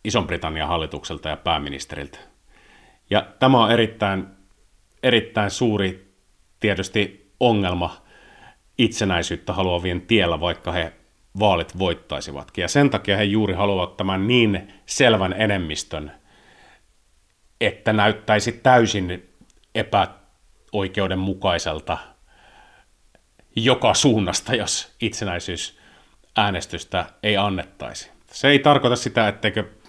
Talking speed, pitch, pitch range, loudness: 90 wpm, 100 Hz, 90-110 Hz, -21 LUFS